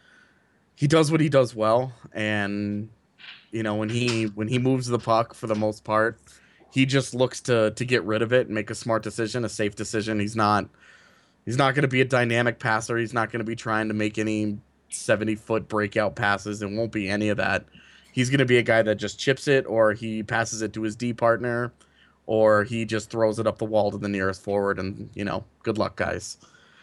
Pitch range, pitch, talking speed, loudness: 105-120 Hz, 110 Hz, 220 wpm, -24 LUFS